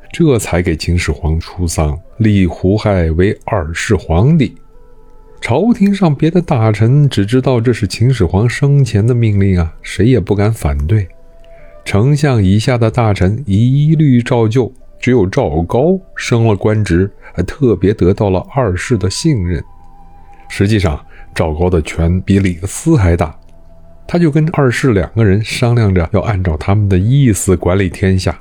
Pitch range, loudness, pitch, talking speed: 90-125 Hz, -13 LUFS, 100 Hz, 230 characters per minute